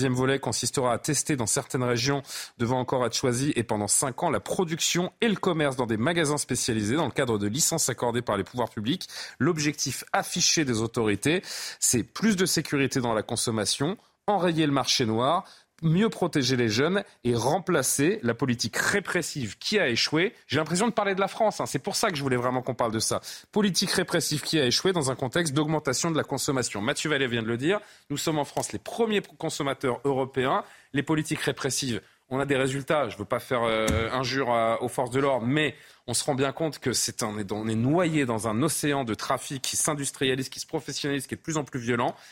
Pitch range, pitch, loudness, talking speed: 120-160 Hz, 140 Hz, -26 LUFS, 220 wpm